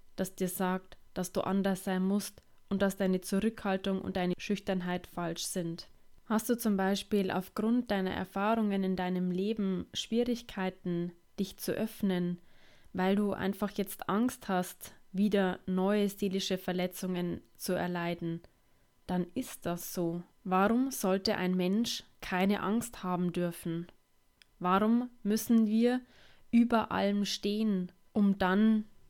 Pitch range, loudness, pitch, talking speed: 180-210 Hz, -32 LUFS, 195 Hz, 130 wpm